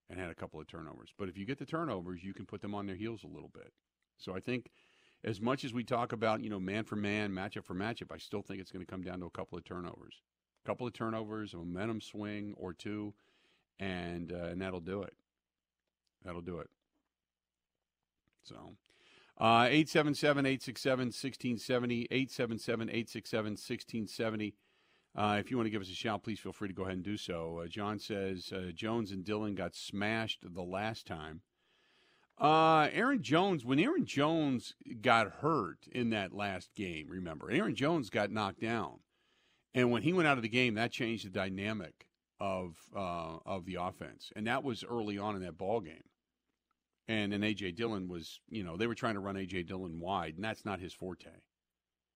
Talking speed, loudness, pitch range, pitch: 195 wpm, -36 LUFS, 90-115 Hz, 105 Hz